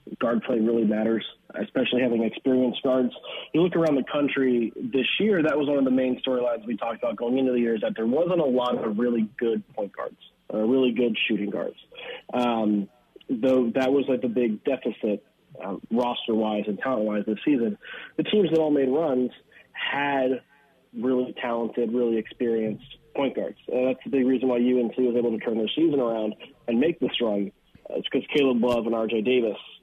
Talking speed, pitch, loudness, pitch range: 195 wpm, 125 Hz, -25 LUFS, 115-130 Hz